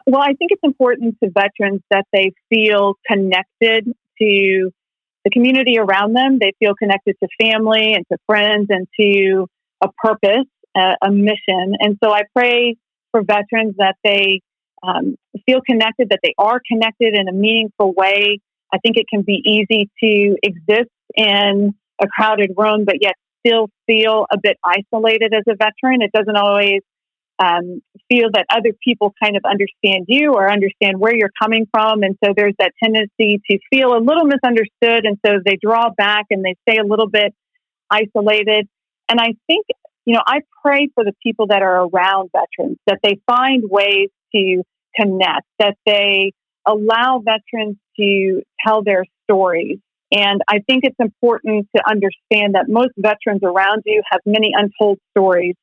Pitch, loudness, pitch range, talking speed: 210 Hz, -15 LUFS, 200-230 Hz, 165 wpm